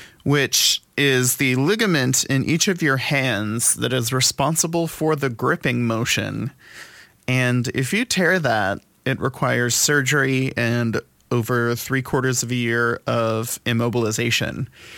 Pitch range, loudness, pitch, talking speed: 120-135 Hz, -20 LUFS, 125 Hz, 130 wpm